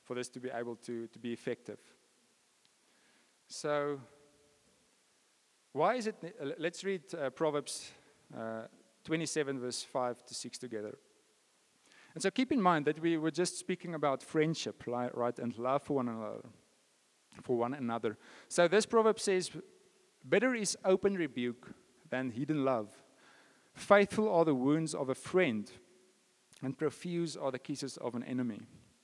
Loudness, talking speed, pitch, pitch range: -34 LUFS, 145 wpm, 145 Hz, 125-175 Hz